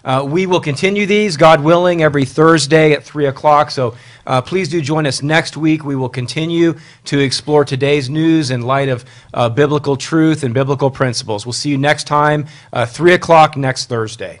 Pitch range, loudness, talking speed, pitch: 130-160 Hz, -14 LUFS, 190 wpm, 145 Hz